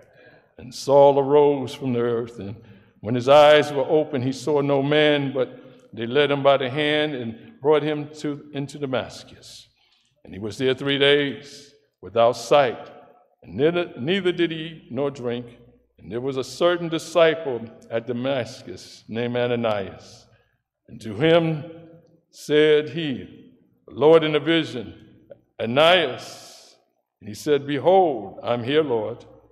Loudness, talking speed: -21 LUFS, 150 wpm